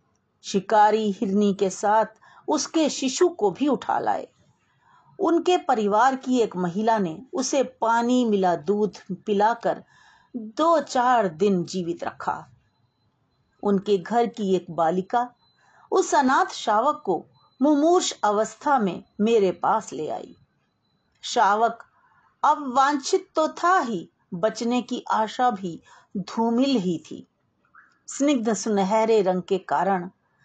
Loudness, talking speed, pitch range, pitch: -23 LUFS, 120 wpm, 195-270 Hz, 225 Hz